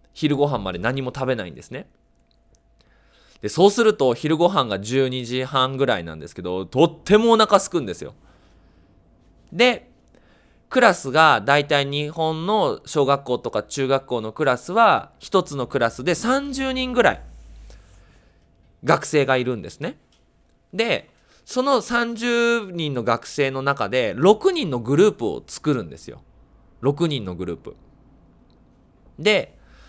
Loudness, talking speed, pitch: -20 LUFS, 250 characters per minute, 135 Hz